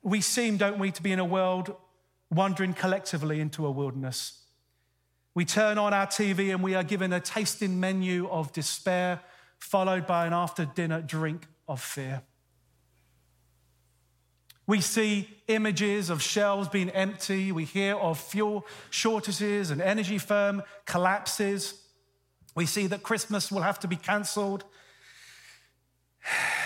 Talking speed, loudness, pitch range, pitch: 135 wpm, -29 LUFS, 155-200 Hz, 185 Hz